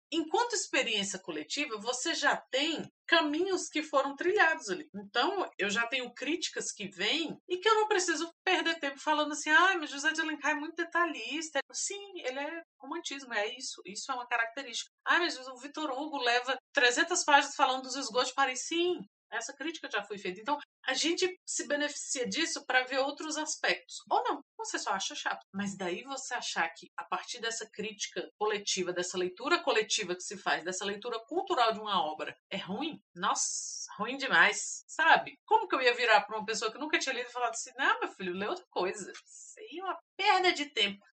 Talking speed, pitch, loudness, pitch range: 195 wpm, 275 Hz, -31 LUFS, 225-330 Hz